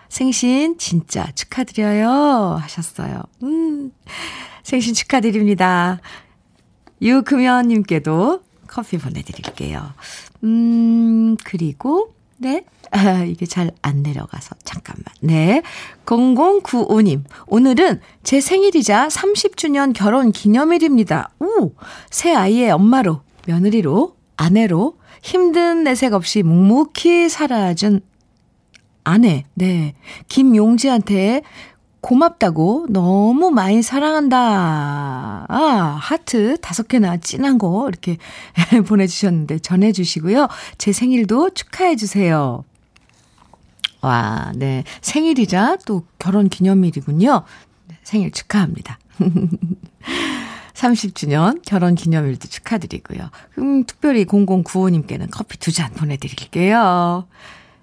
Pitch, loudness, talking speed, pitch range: 210 Hz, -16 LUFS, 220 characters per minute, 175-260 Hz